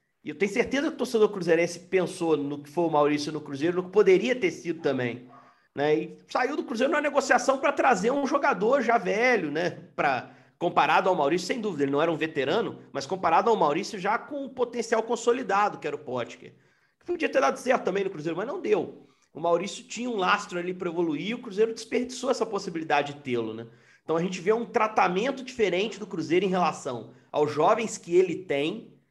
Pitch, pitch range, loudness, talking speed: 200 Hz, 165-245 Hz, -26 LUFS, 210 wpm